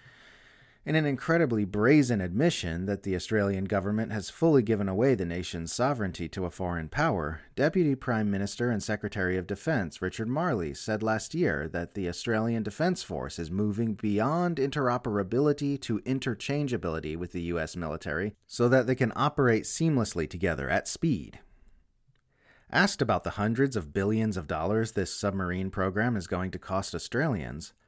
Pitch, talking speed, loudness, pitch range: 105 Hz, 155 wpm, -29 LUFS, 95-130 Hz